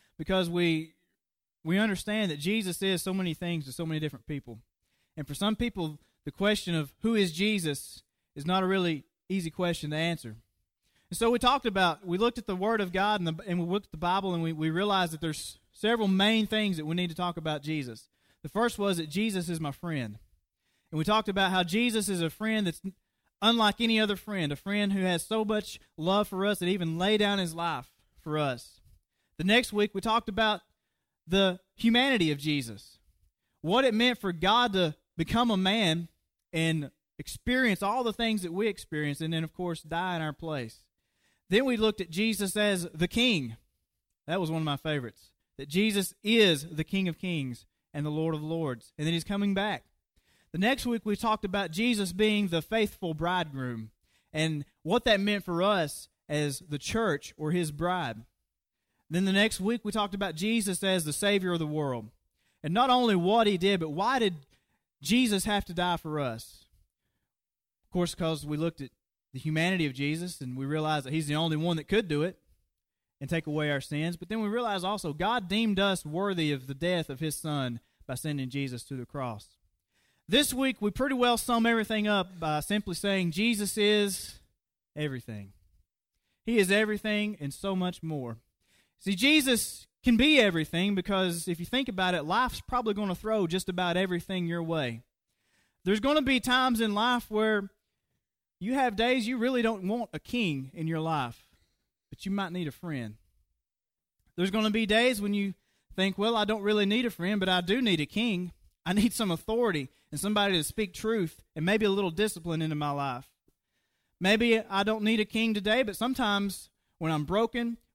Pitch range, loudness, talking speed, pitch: 155-210 Hz, -29 LUFS, 200 wpm, 180 Hz